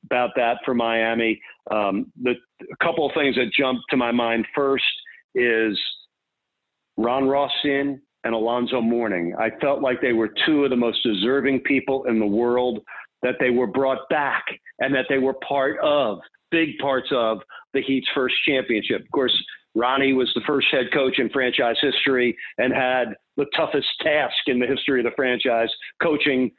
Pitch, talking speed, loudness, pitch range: 125 Hz, 175 wpm, -22 LUFS, 115-135 Hz